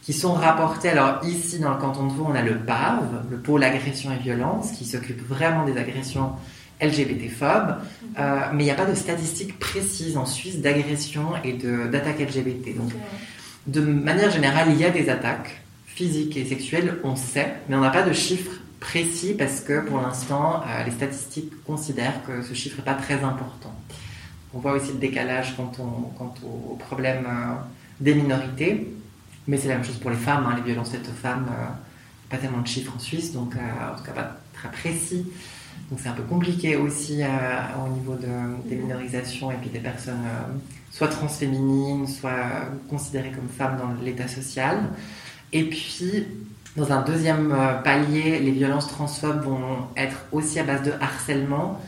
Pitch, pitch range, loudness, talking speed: 135 Hz, 125-150 Hz, -25 LUFS, 185 wpm